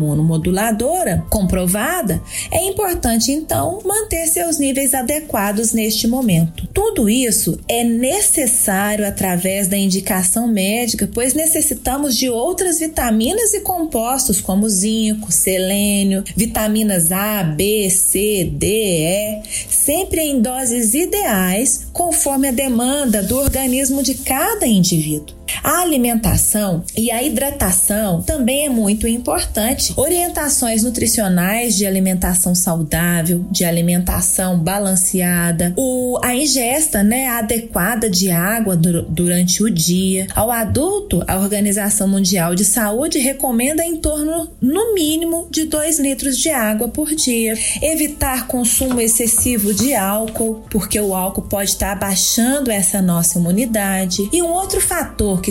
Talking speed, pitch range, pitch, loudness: 120 wpm, 195-275 Hz, 225 Hz, -16 LUFS